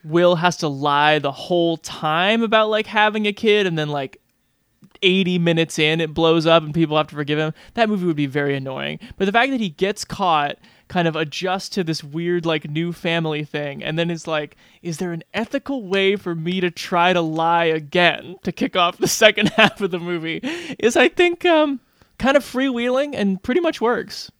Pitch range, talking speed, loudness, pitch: 160-210 Hz, 210 wpm, -19 LUFS, 175 Hz